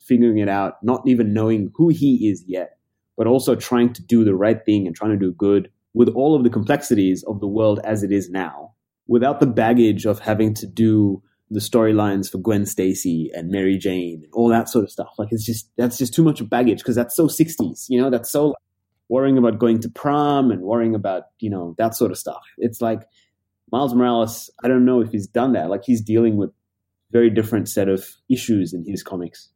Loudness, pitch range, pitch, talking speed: -19 LUFS, 100-120 Hz, 110 Hz, 225 wpm